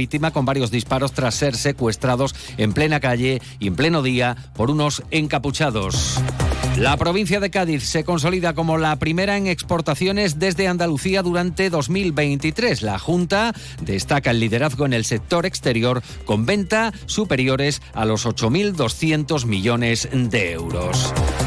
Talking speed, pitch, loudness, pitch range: 135 wpm, 145 Hz, -20 LUFS, 125-170 Hz